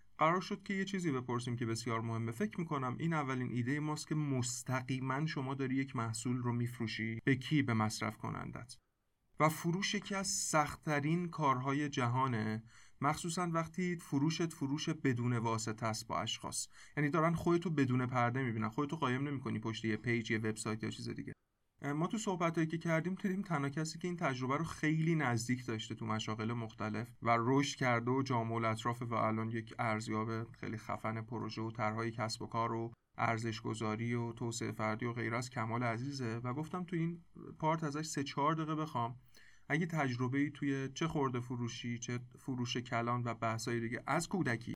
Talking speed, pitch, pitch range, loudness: 180 wpm, 125 Hz, 115-150 Hz, -37 LUFS